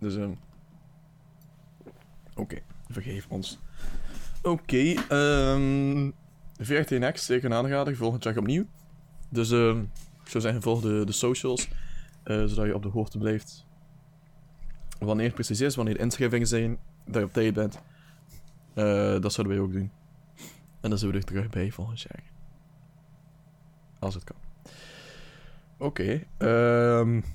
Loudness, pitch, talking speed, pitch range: -28 LUFS, 140 Hz, 155 wpm, 110-155 Hz